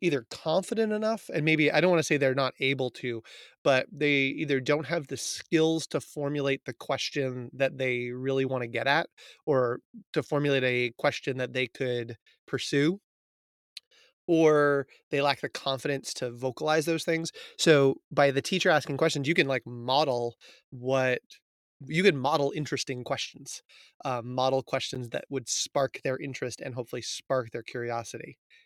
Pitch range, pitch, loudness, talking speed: 130-155 Hz, 140 Hz, -28 LUFS, 165 wpm